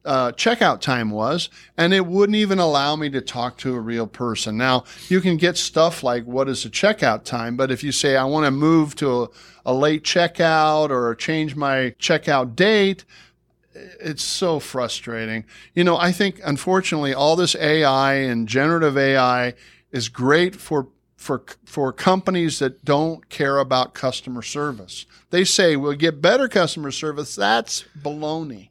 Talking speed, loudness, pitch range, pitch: 165 wpm, -20 LUFS, 130-170 Hz, 145 Hz